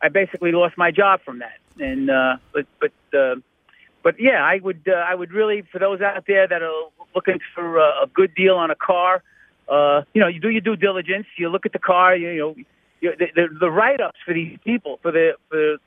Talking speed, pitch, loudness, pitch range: 230 wpm, 185 Hz, -19 LUFS, 170-205 Hz